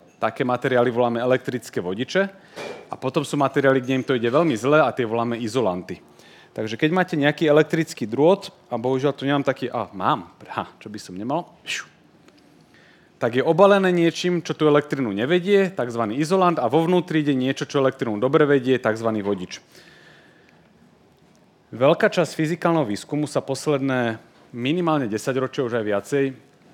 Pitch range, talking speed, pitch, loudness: 120-160 Hz, 160 wpm, 135 Hz, -22 LUFS